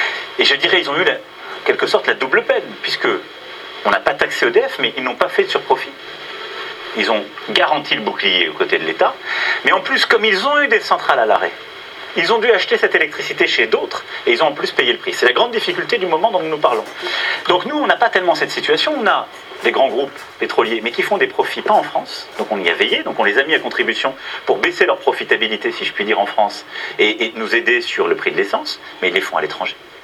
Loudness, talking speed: -16 LUFS, 260 wpm